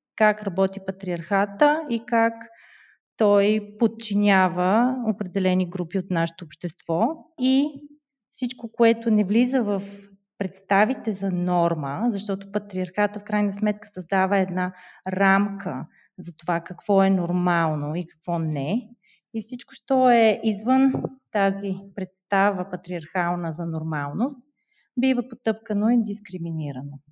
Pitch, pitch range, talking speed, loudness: 200 Hz, 180-230 Hz, 115 wpm, -24 LUFS